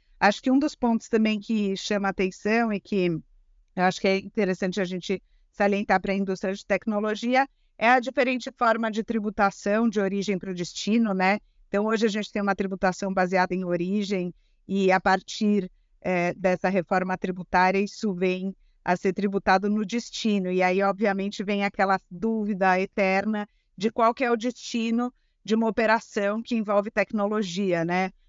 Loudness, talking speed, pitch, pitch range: -25 LUFS, 170 wpm, 200 Hz, 190-220 Hz